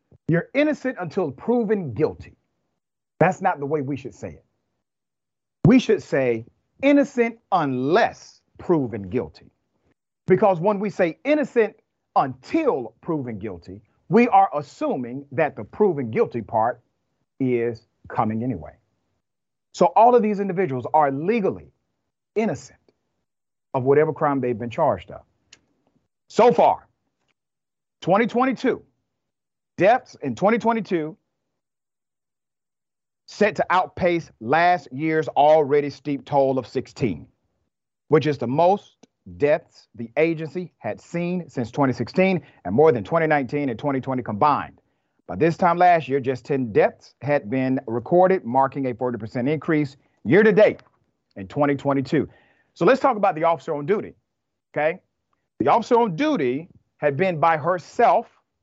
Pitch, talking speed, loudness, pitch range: 155 Hz, 130 wpm, -21 LUFS, 130-190 Hz